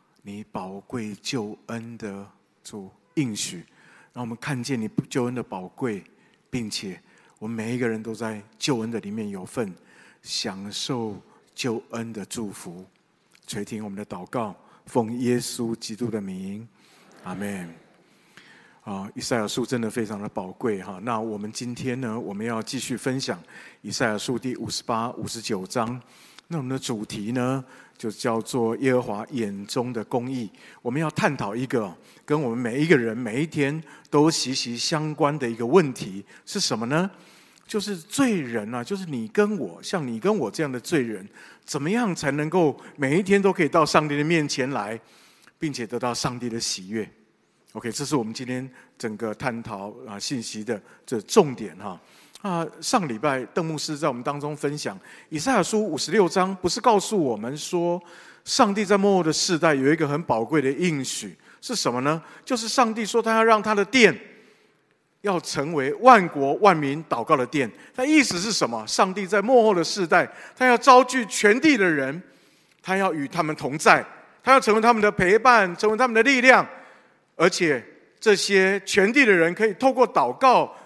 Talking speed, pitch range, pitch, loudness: 255 characters per minute, 115-195 Hz, 140 Hz, -23 LUFS